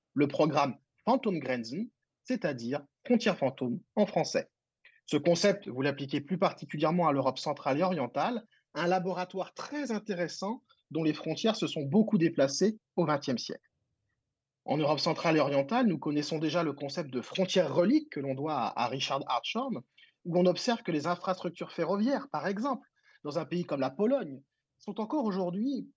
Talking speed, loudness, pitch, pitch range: 165 wpm, -31 LUFS, 175 Hz, 150-210 Hz